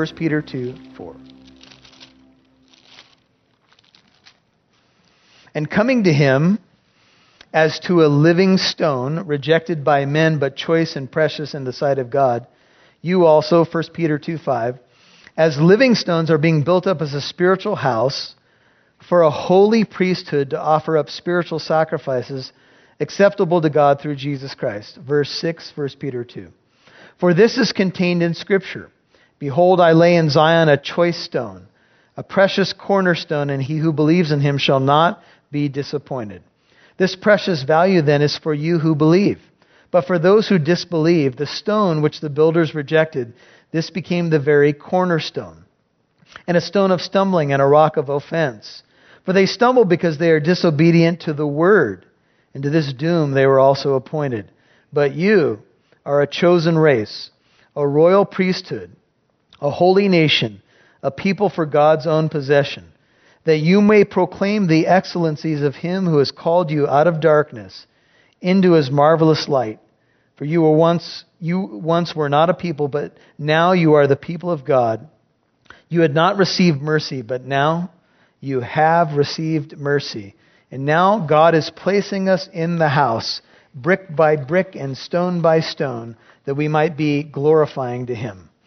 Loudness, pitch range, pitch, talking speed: -17 LUFS, 140-175 Hz, 155 Hz, 155 wpm